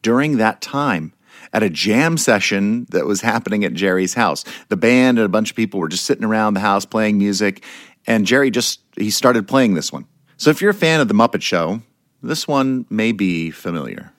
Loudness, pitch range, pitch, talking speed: -17 LUFS, 100-130 Hz, 110 Hz, 210 wpm